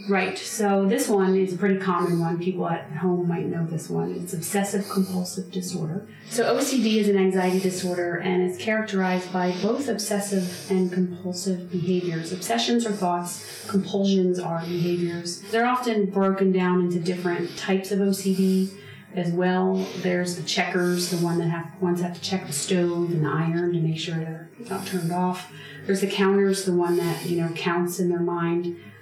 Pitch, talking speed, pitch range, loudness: 180 Hz, 180 wpm, 175-195 Hz, -24 LUFS